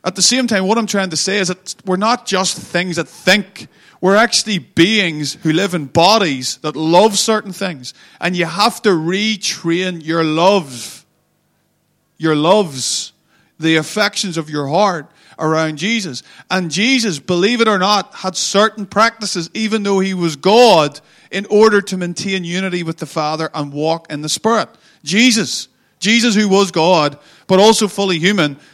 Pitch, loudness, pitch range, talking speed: 185 Hz, -15 LUFS, 160-205 Hz, 165 wpm